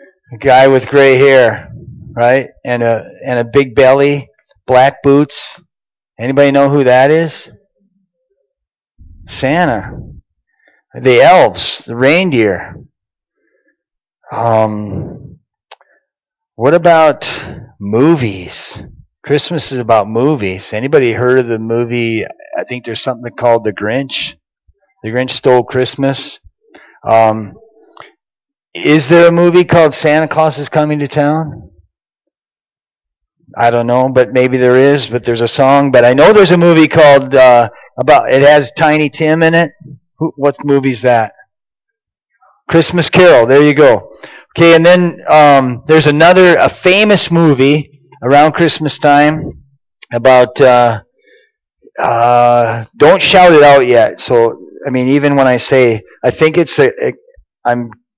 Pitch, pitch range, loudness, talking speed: 140 Hz, 120-155 Hz, -9 LUFS, 130 wpm